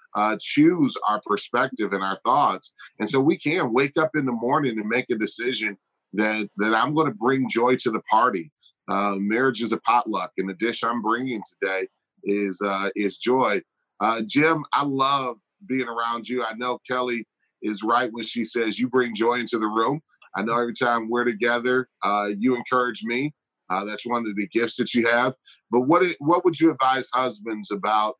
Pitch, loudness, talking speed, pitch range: 120 Hz, -23 LUFS, 200 wpm, 110-130 Hz